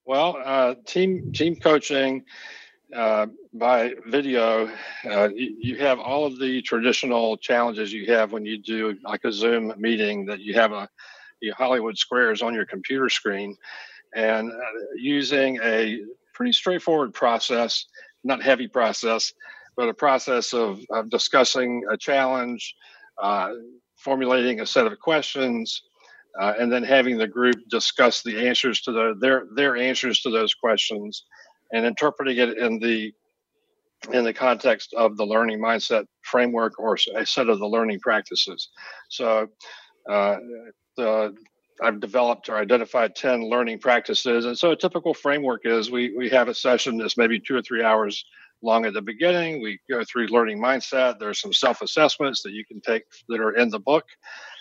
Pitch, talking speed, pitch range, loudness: 120 Hz, 160 wpm, 110-135 Hz, -23 LUFS